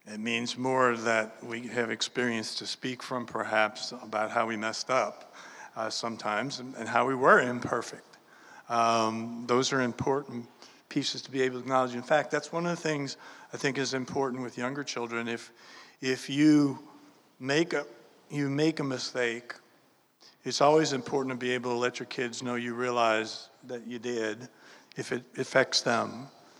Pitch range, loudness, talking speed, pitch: 115-135 Hz, -29 LUFS, 175 wpm, 125 Hz